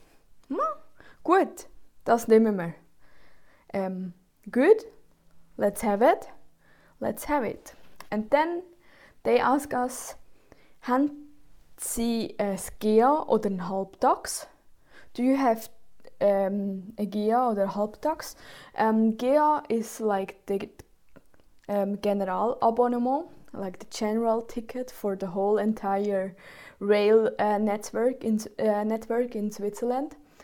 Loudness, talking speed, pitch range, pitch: -27 LUFS, 110 wpm, 205-255 Hz, 225 Hz